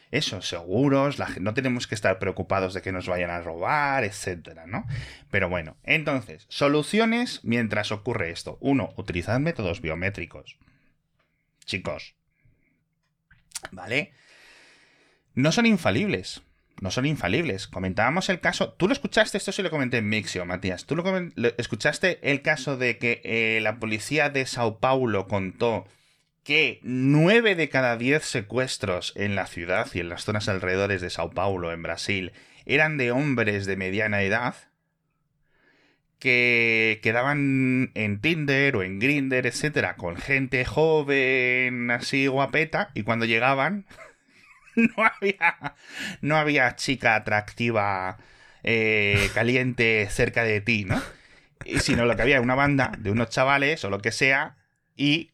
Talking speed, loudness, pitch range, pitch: 145 wpm, -24 LUFS, 100-145 Hz, 125 Hz